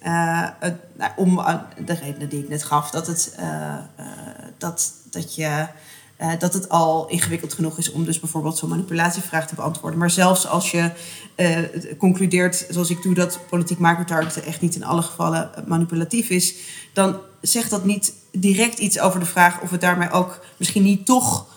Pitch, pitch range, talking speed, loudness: 170 Hz, 160-180 Hz, 185 wpm, -21 LUFS